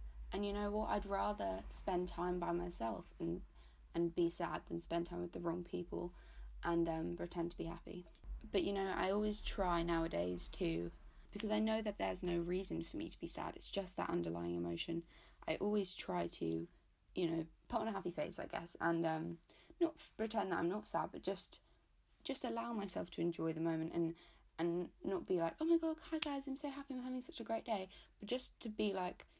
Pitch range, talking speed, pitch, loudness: 160-210 Hz, 215 wpm, 175 Hz, -42 LUFS